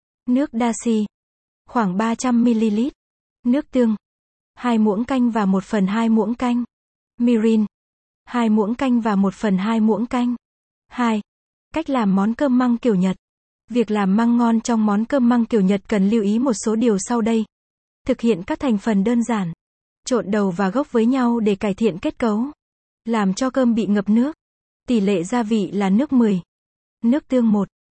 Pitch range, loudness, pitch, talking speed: 215-245 Hz, -20 LUFS, 230 Hz, 185 wpm